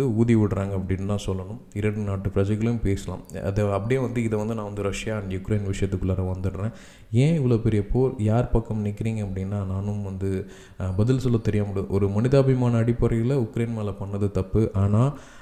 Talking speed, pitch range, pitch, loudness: 165 wpm, 100-115 Hz, 105 Hz, -25 LUFS